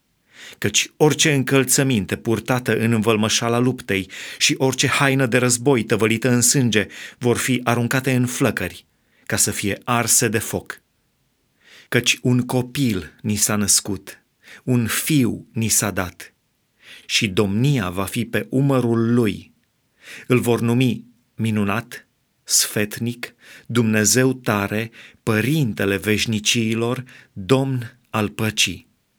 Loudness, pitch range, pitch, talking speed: -19 LUFS, 105-125 Hz, 115 Hz, 115 wpm